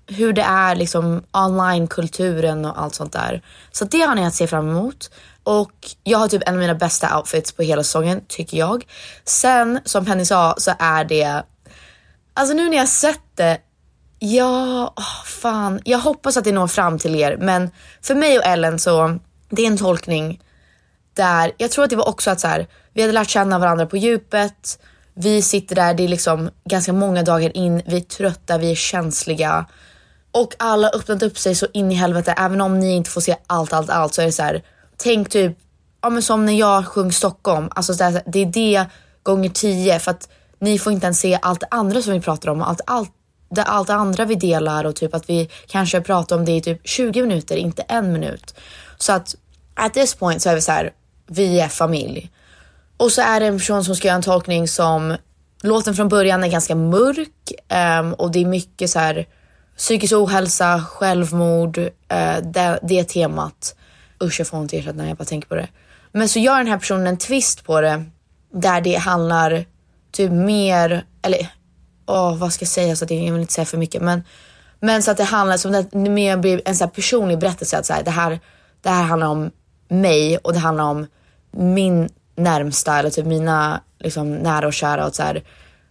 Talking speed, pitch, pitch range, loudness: 210 wpm, 180 Hz, 165-205 Hz, -18 LUFS